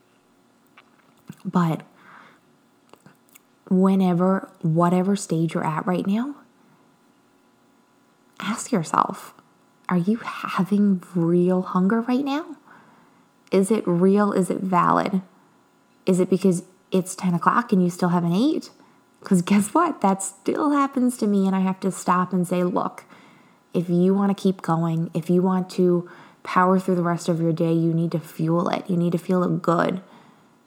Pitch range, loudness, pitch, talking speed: 175-205 Hz, -22 LUFS, 185 Hz, 155 wpm